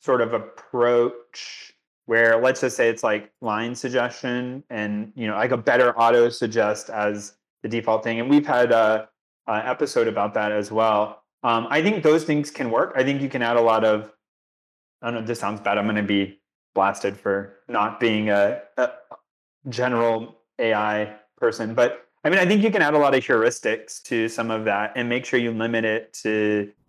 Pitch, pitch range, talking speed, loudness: 115 Hz, 105-125 Hz, 200 wpm, -22 LUFS